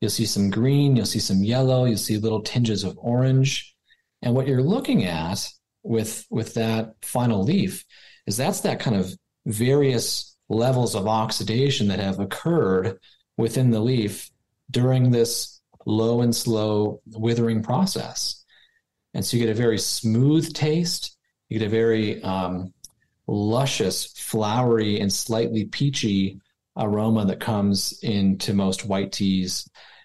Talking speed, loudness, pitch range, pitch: 140 wpm, -23 LUFS, 105-125 Hz, 115 Hz